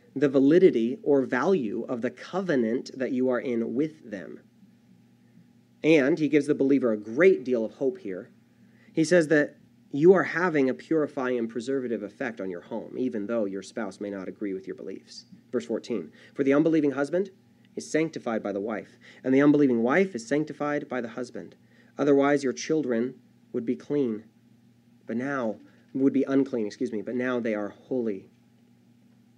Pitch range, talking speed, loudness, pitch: 115-145 Hz, 175 wpm, -26 LUFS, 130 Hz